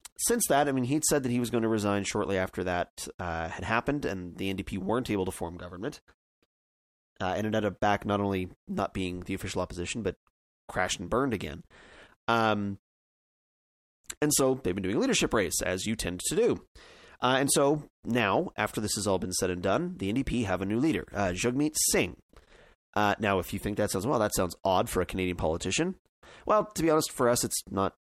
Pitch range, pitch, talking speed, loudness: 90-120 Hz, 100 Hz, 215 wpm, -29 LUFS